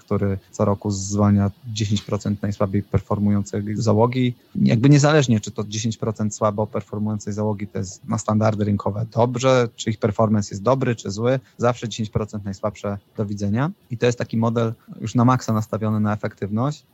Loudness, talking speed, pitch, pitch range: -22 LUFS, 160 wpm, 110 Hz, 105-115 Hz